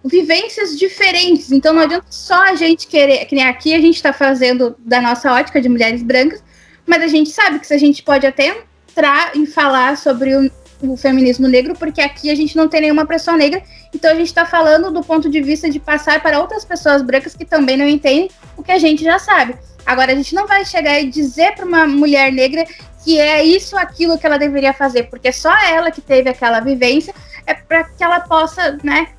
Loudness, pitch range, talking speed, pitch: -13 LUFS, 275-335 Hz, 220 wpm, 305 Hz